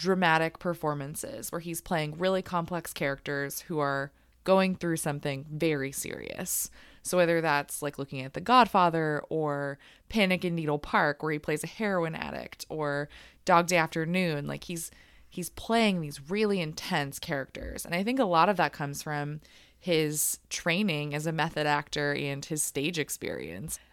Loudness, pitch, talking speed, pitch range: -29 LUFS, 160 Hz, 165 wpm, 145-175 Hz